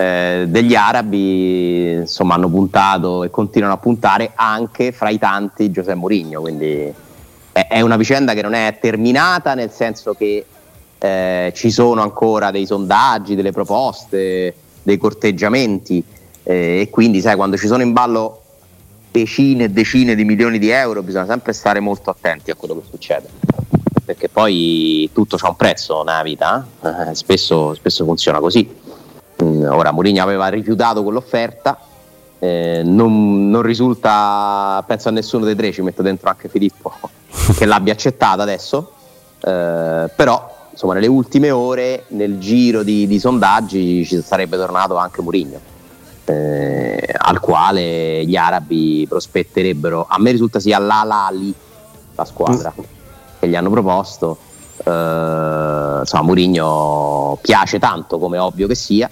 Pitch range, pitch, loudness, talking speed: 90-110 Hz, 100 Hz, -15 LUFS, 140 wpm